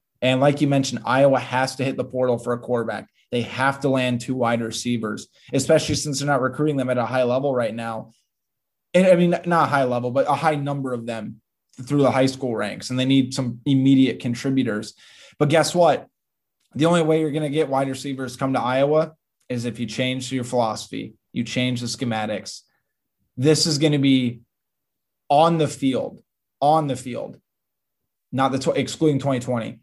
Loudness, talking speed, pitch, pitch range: -21 LUFS, 195 wpm, 130 Hz, 120-145 Hz